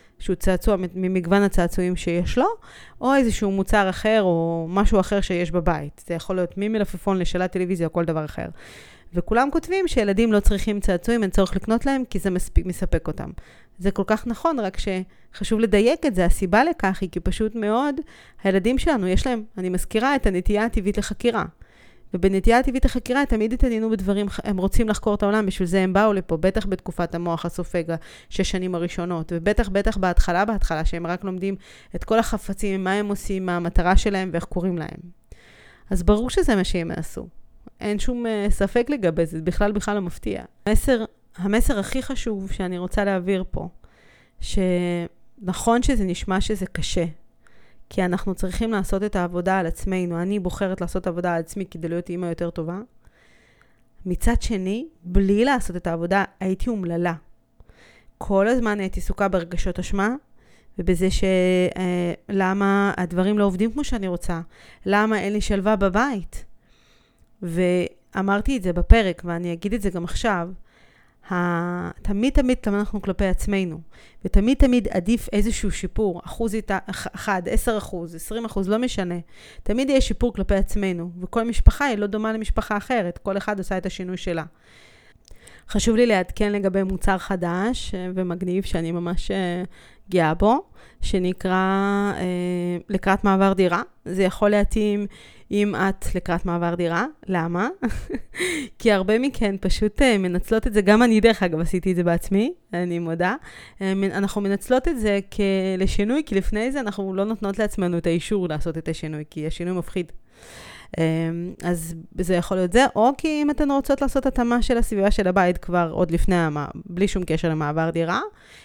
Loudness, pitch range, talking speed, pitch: -23 LUFS, 180-215 Hz, 160 wpm, 195 Hz